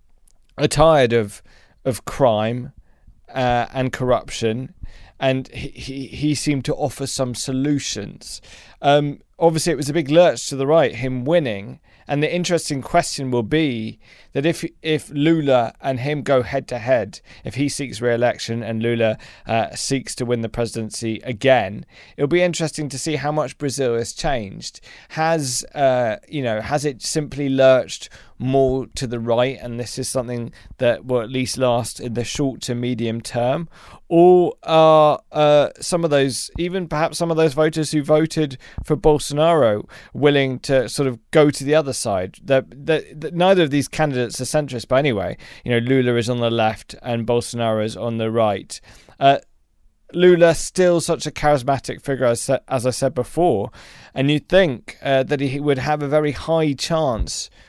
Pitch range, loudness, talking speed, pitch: 120-150 Hz, -19 LUFS, 175 wpm, 135 Hz